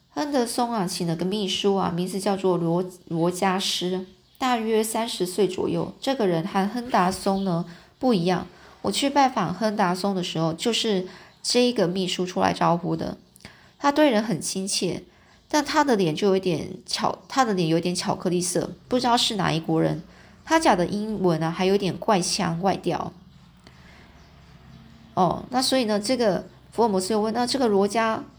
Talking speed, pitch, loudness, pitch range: 255 characters per minute, 195 Hz, -24 LUFS, 180-225 Hz